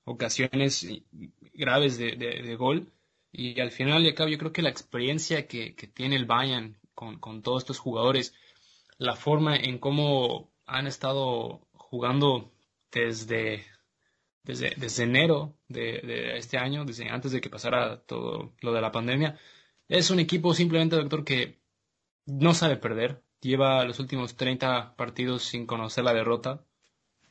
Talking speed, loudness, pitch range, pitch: 155 wpm, -27 LUFS, 120-145 Hz, 130 Hz